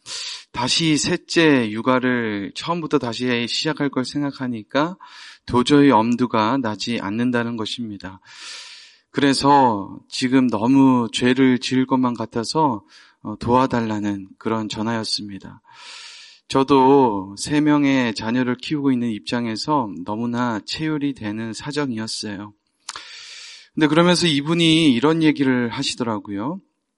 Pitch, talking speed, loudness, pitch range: 130 Hz, 260 characters per minute, -20 LUFS, 115-150 Hz